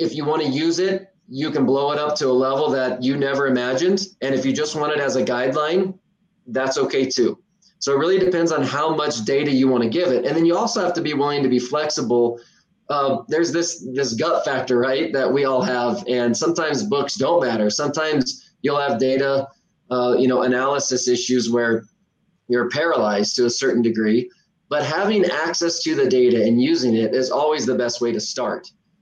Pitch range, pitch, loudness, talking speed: 125-170 Hz, 140 Hz, -20 LUFS, 210 wpm